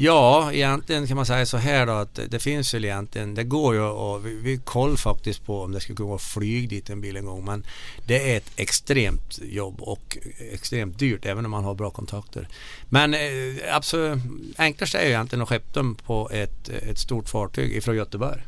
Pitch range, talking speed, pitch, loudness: 105-135 Hz, 205 wpm, 115 Hz, -25 LUFS